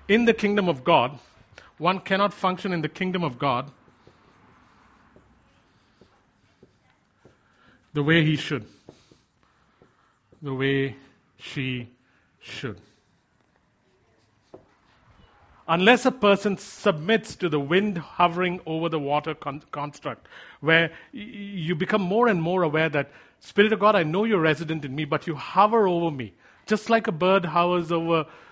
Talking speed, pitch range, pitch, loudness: 135 wpm, 145-200 Hz, 165 Hz, -24 LUFS